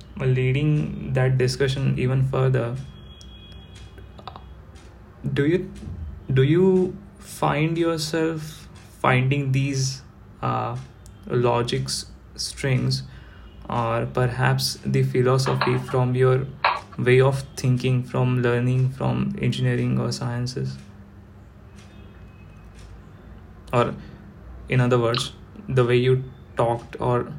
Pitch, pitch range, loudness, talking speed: 125 Hz, 95-130 Hz, -23 LUFS, 90 wpm